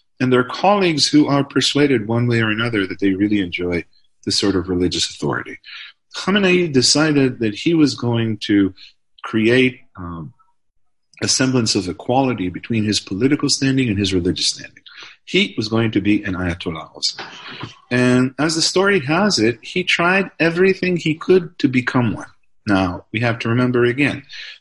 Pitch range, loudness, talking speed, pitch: 100-150 Hz, -17 LUFS, 165 wpm, 125 Hz